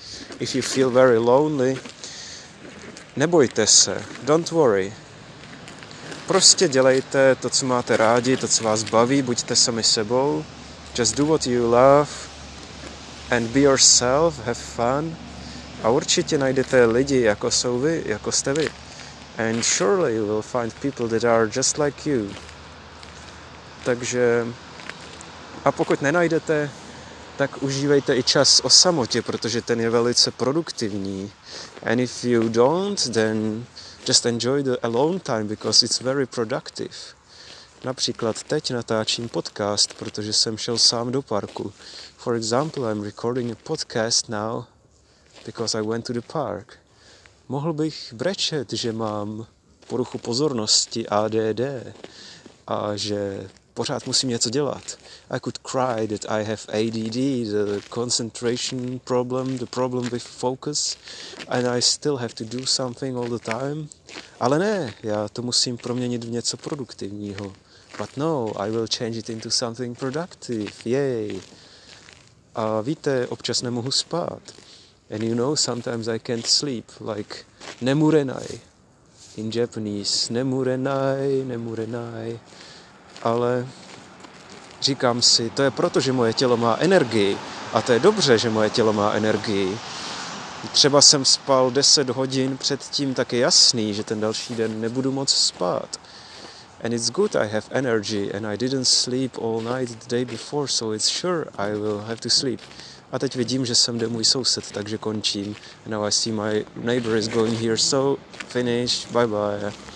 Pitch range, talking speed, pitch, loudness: 110-130 Hz, 145 wpm, 120 Hz, -21 LUFS